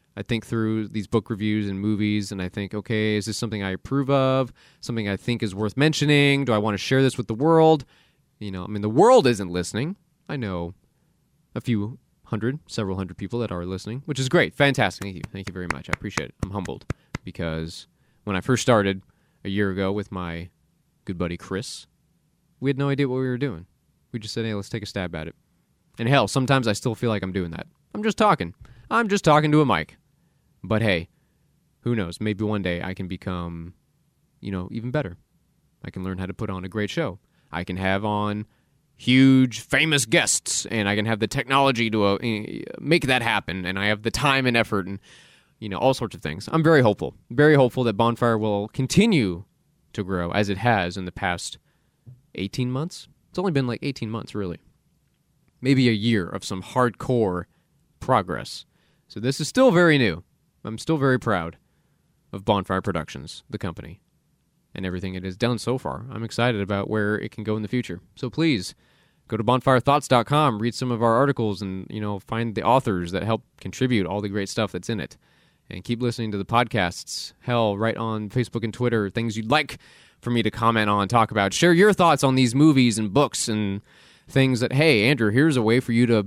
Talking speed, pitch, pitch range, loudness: 210 wpm, 110 Hz, 100-130 Hz, -23 LUFS